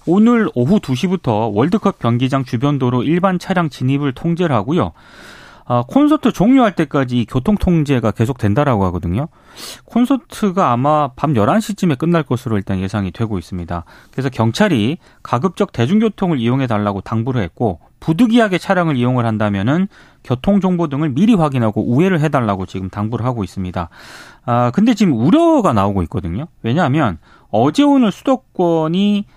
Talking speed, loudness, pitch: 360 characters per minute, -16 LUFS, 140 Hz